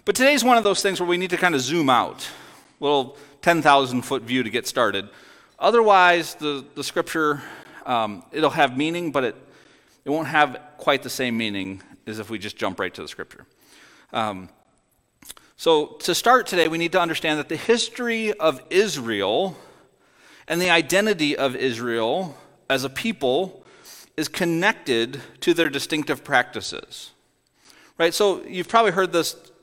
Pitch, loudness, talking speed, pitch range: 160 Hz, -21 LUFS, 175 wpm, 135-185 Hz